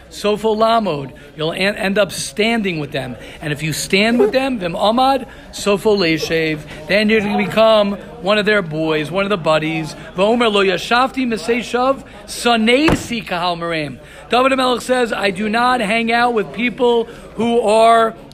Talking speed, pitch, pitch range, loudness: 135 wpm, 210 Hz, 165-235 Hz, -16 LUFS